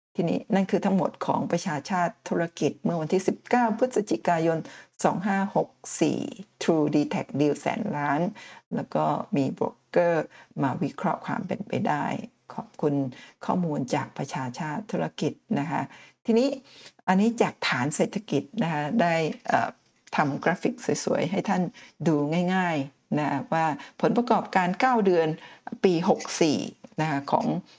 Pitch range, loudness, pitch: 155-225 Hz, -26 LUFS, 185 Hz